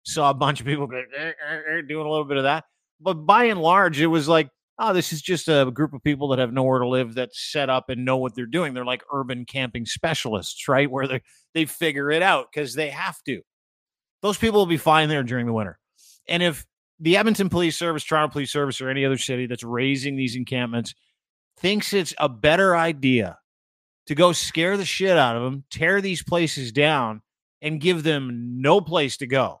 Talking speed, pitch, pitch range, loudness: 215 wpm, 145 Hz, 130-165 Hz, -22 LUFS